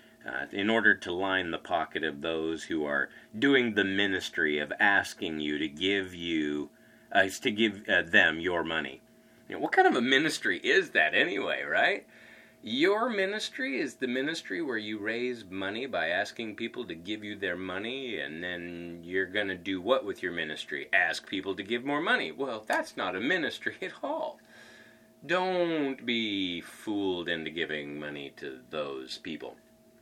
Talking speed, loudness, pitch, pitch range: 175 wpm, -29 LUFS, 105 Hz, 85-135 Hz